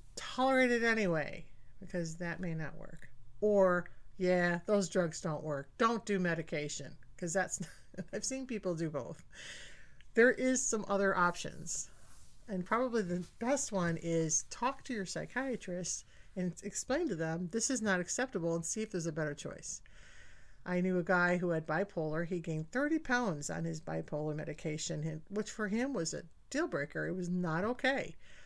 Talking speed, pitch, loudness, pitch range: 170 wpm, 180 Hz, -35 LUFS, 160-220 Hz